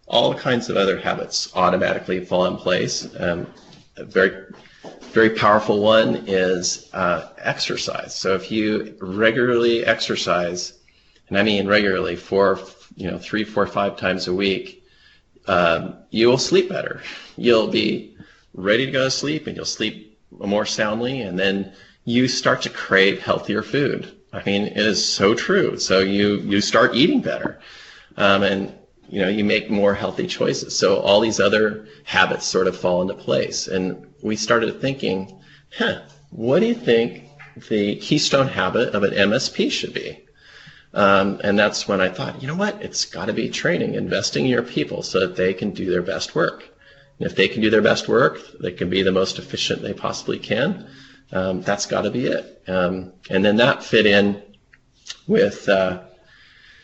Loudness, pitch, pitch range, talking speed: -20 LUFS, 100 Hz, 95-110 Hz, 175 wpm